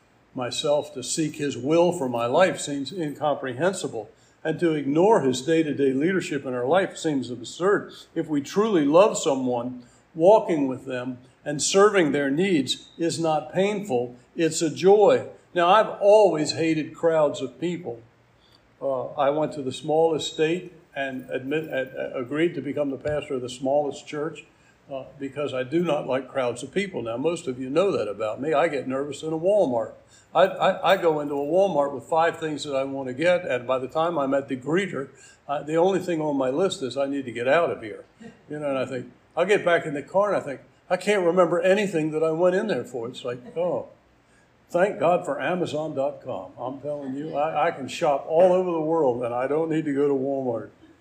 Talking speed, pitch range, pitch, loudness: 205 wpm, 135-170 Hz, 150 Hz, -24 LUFS